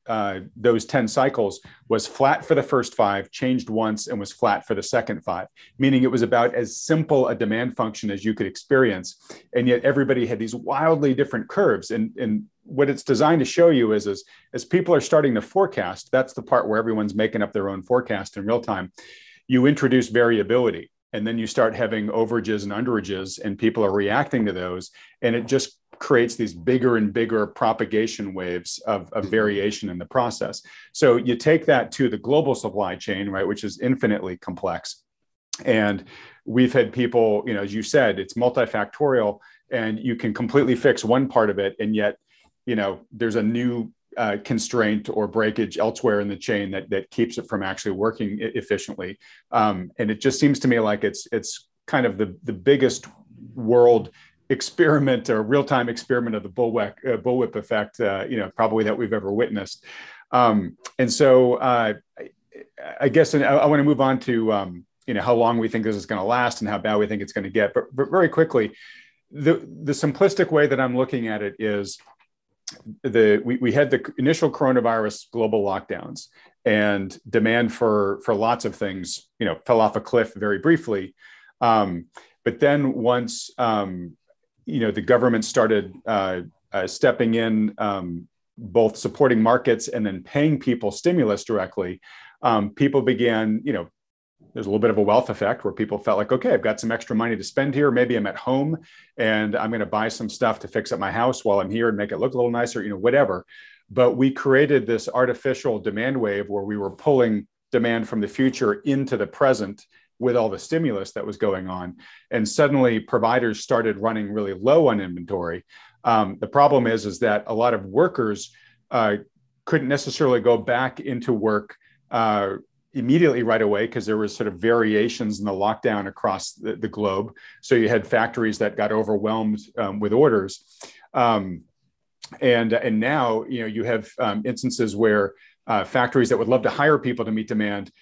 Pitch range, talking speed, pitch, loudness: 105-130 Hz, 195 wpm, 115 Hz, -22 LUFS